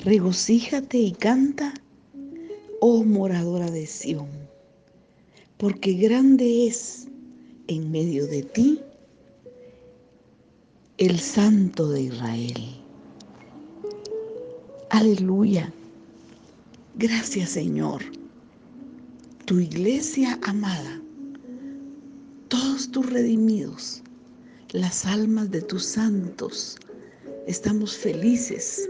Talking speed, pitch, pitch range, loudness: 70 wpm, 235 Hz, 190-270 Hz, -23 LUFS